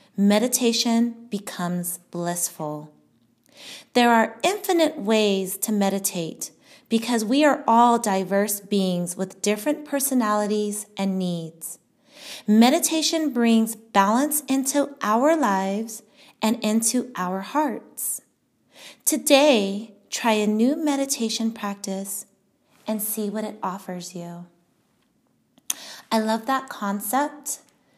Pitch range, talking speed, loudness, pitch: 195-265 Hz, 100 wpm, -23 LUFS, 220 Hz